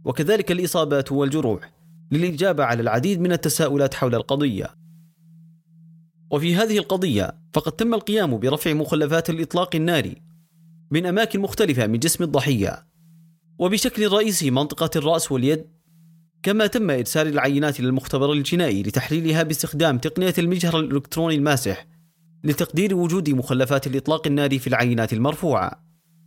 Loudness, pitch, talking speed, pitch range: -21 LUFS, 165 Hz, 115 wpm, 140-170 Hz